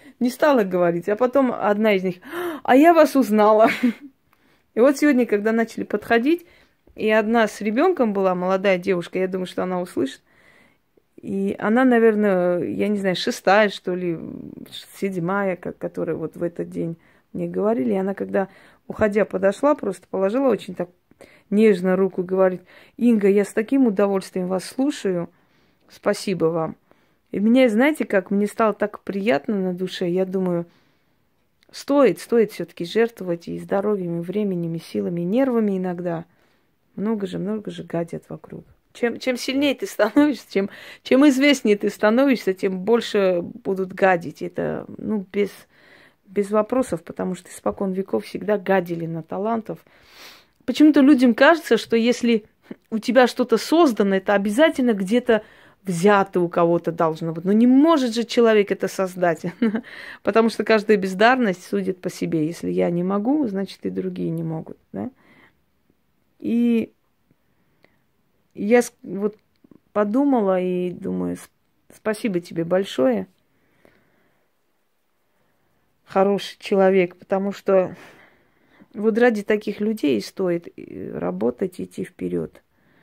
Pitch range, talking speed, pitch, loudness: 185-235 Hz, 135 wpm, 205 Hz, -21 LUFS